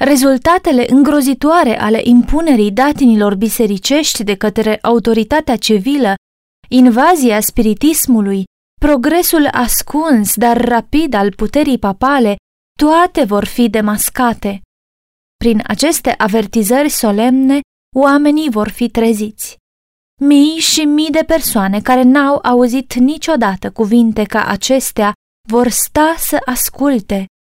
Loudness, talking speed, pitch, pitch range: -12 LUFS, 100 wpm, 245 Hz, 215-285 Hz